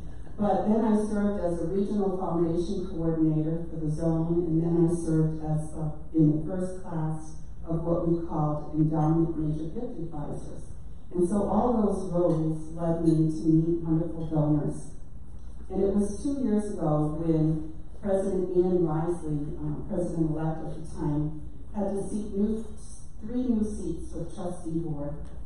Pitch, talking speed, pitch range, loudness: 165 Hz, 155 wpm, 155-190 Hz, -28 LUFS